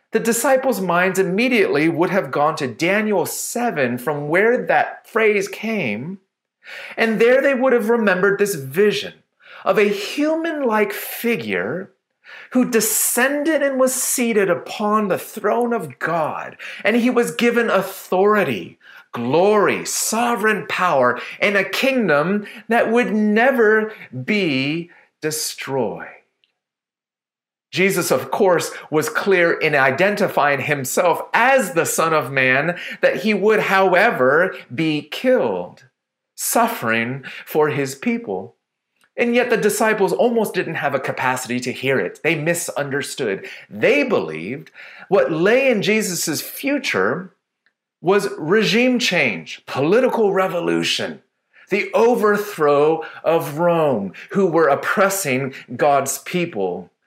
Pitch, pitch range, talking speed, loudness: 200 Hz, 160-230 Hz, 120 wpm, -18 LUFS